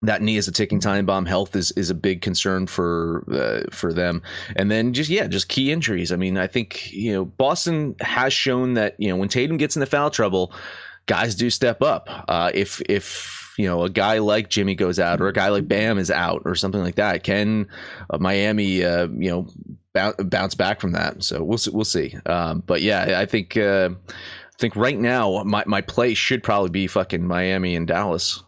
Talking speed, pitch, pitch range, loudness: 215 wpm, 100 Hz, 95-115 Hz, -21 LUFS